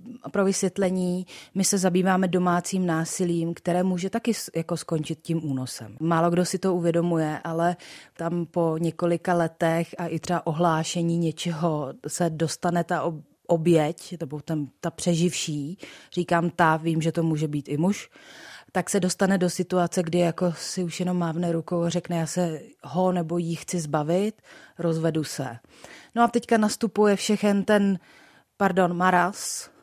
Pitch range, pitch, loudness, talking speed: 165-185 Hz, 175 Hz, -25 LUFS, 155 wpm